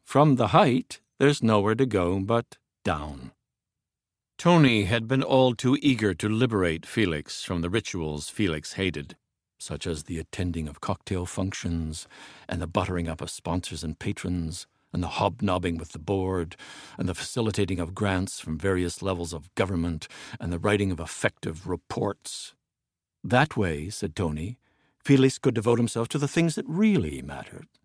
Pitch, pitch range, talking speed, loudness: 95 Hz, 85-115 Hz, 160 wpm, -26 LUFS